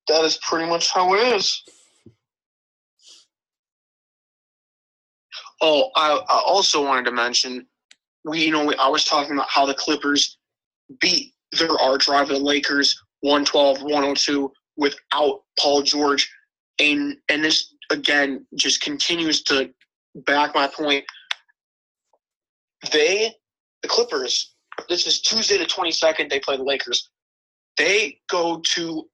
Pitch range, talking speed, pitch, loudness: 140-180 Hz, 120 wpm, 150 Hz, -19 LUFS